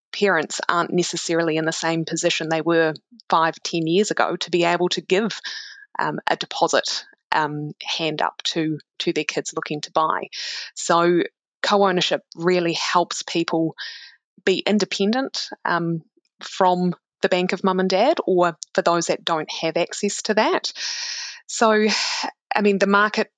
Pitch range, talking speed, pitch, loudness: 165-200 Hz, 155 wpm, 175 Hz, -21 LUFS